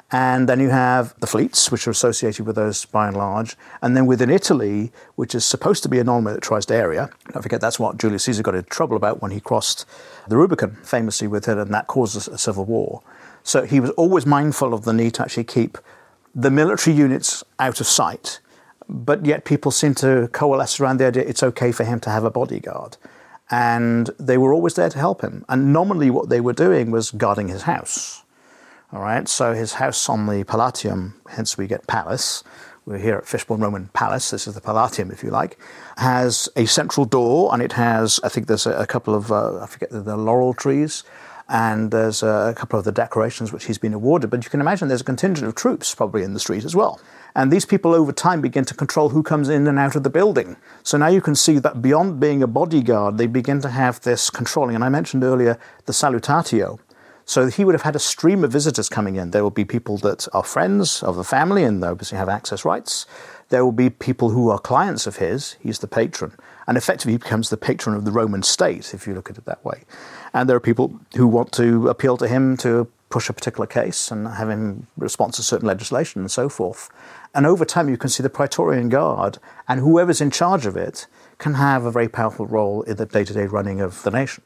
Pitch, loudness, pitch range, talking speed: 120 Hz, -19 LUFS, 110-140 Hz, 230 wpm